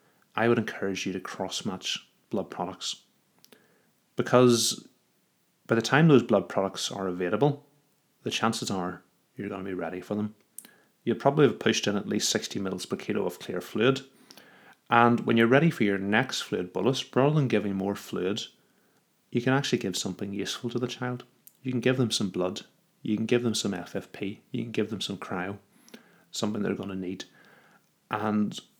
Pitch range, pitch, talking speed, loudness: 100-125 Hz, 110 Hz, 185 wpm, -28 LUFS